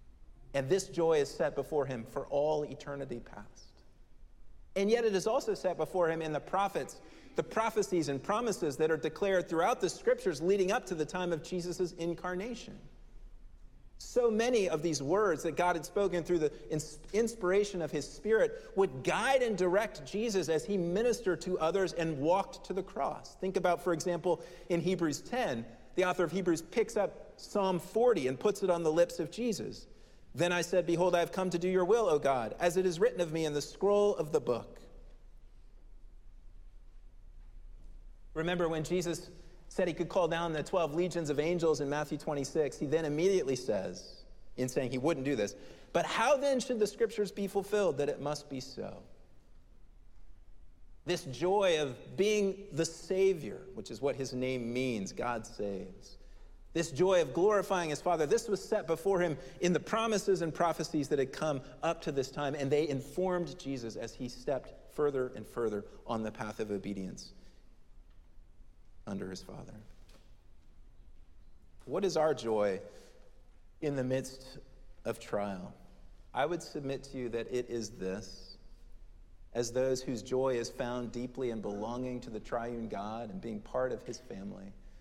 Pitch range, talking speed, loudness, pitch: 125-185 Hz, 175 wpm, -33 LUFS, 155 Hz